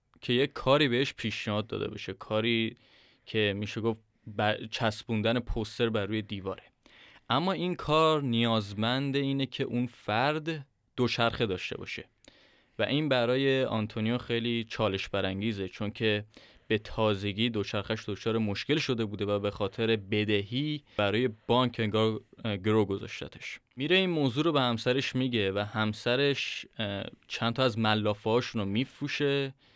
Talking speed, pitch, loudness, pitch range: 135 wpm, 115 Hz, -30 LUFS, 105-130 Hz